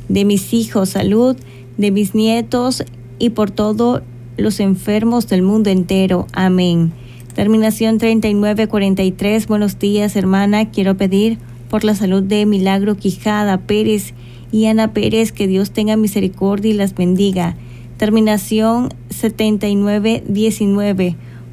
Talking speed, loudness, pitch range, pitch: 115 wpm, -15 LUFS, 190-215 Hz, 205 Hz